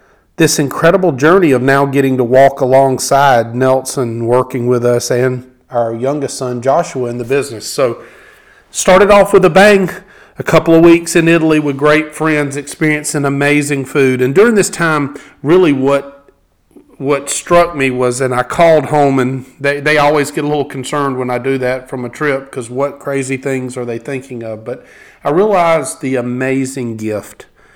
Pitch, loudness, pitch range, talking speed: 135 Hz, -12 LUFS, 130-150 Hz, 175 wpm